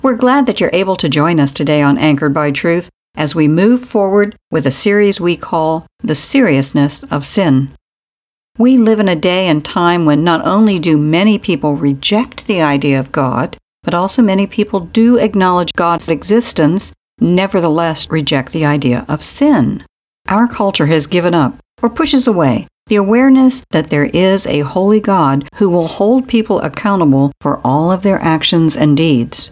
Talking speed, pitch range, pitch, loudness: 175 wpm, 150-210 Hz, 175 Hz, -12 LUFS